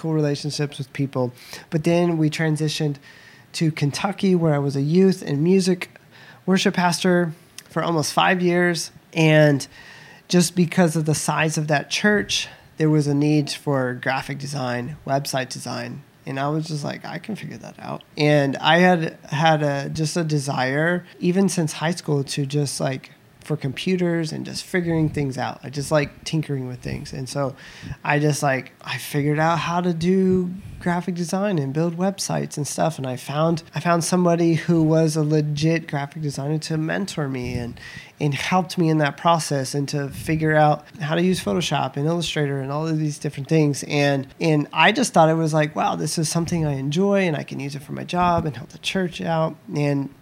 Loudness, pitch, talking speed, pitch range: -22 LUFS, 155 Hz, 195 wpm, 140-170 Hz